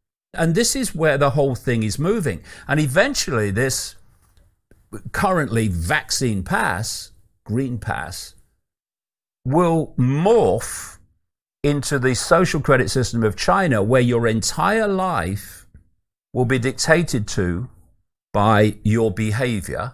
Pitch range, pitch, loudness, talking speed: 100-145 Hz, 120 Hz, -20 LUFS, 110 wpm